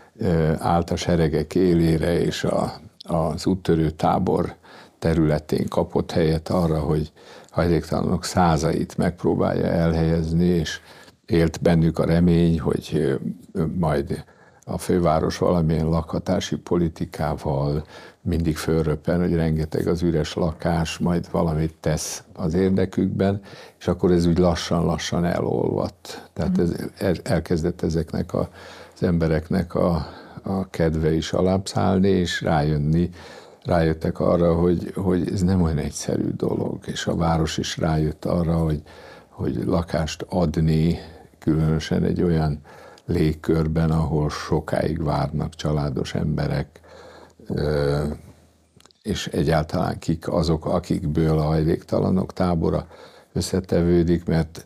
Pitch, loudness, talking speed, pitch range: 80 Hz, -22 LUFS, 110 wpm, 80-85 Hz